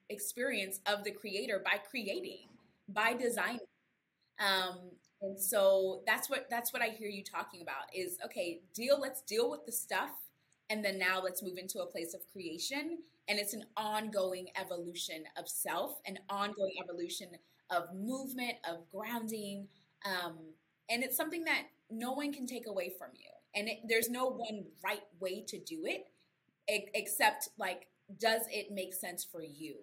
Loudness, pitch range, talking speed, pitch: -37 LUFS, 185-235 Hz, 165 wpm, 205 Hz